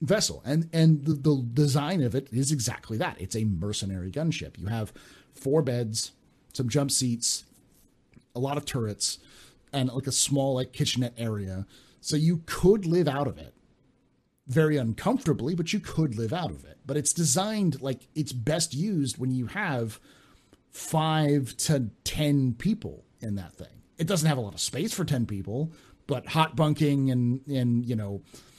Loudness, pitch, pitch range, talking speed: -27 LUFS, 135 Hz, 115-155 Hz, 175 wpm